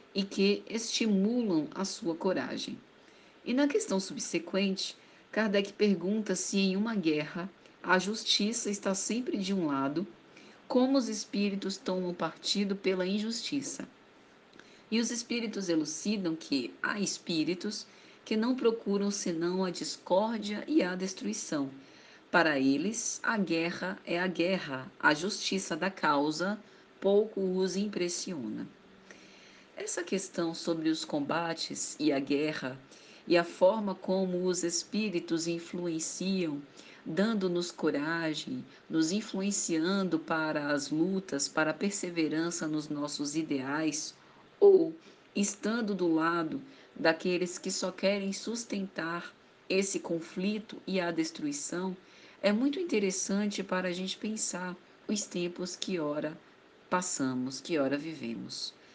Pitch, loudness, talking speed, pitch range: 185 Hz, -32 LUFS, 120 wpm, 165-205 Hz